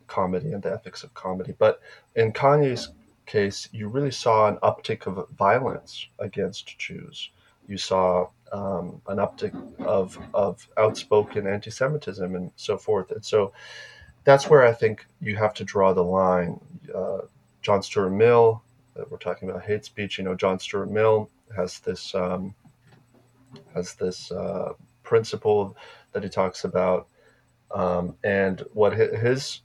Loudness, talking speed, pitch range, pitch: -24 LUFS, 145 wpm, 95-140 Hz, 110 Hz